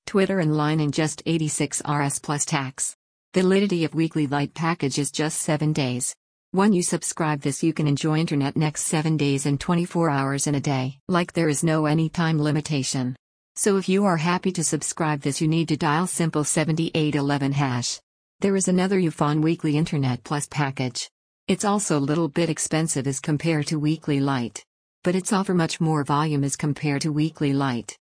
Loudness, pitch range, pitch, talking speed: -23 LUFS, 145-165 Hz, 155 Hz, 190 wpm